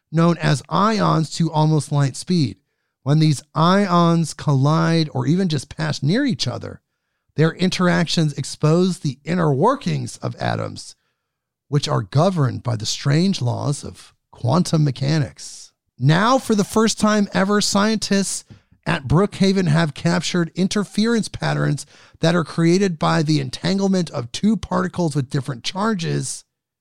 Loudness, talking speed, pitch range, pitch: -19 LUFS, 135 wpm, 140-185 Hz, 160 Hz